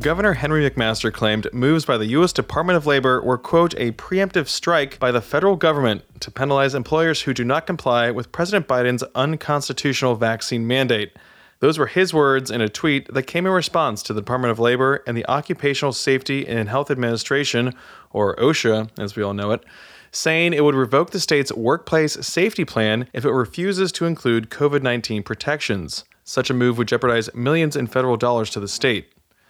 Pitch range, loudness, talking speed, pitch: 120-150 Hz, -20 LUFS, 185 wpm, 130 Hz